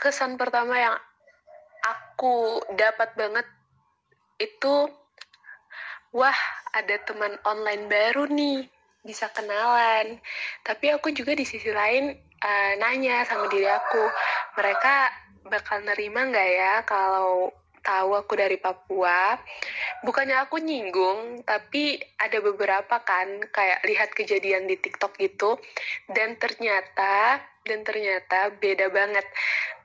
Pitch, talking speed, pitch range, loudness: 220 Hz, 110 wpm, 200-250 Hz, -24 LUFS